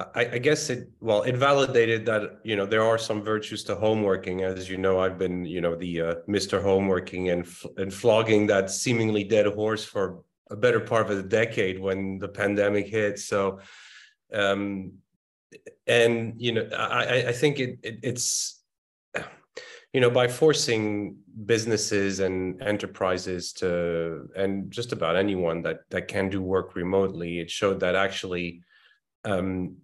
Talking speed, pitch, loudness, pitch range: 160 wpm, 100 Hz, -26 LUFS, 95-115 Hz